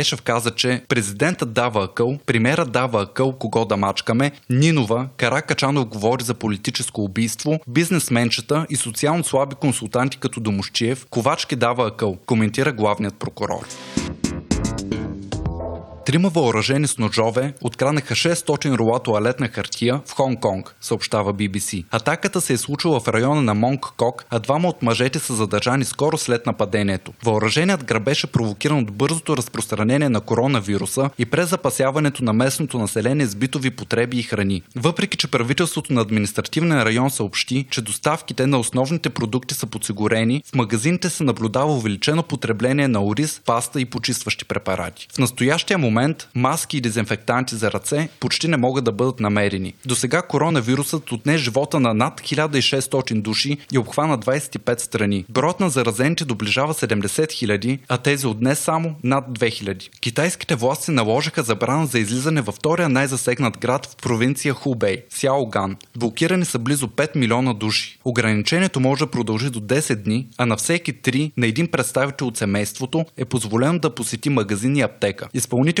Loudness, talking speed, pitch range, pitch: -20 LUFS, 155 wpm, 115-145 Hz, 125 Hz